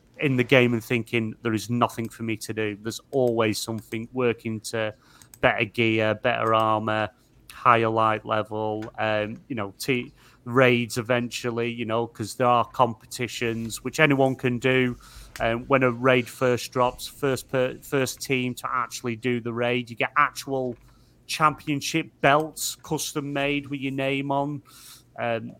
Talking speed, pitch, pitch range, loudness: 160 wpm, 120 Hz, 115-130 Hz, -25 LUFS